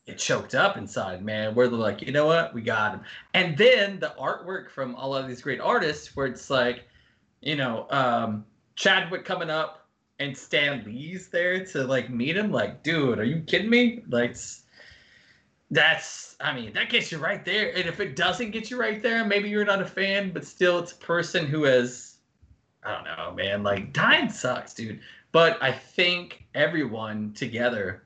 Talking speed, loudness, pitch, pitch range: 190 wpm, -25 LUFS, 150 Hz, 120-185 Hz